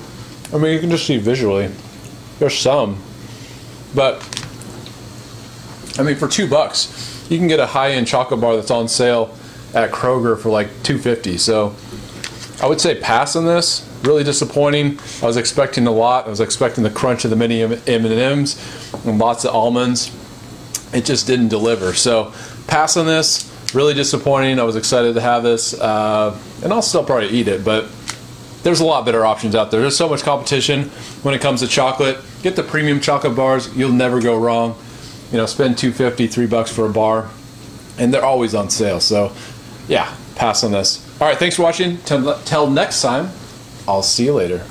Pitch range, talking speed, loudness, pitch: 115-140 Hz, 190 wpm, -16 LUFS, 120 Hz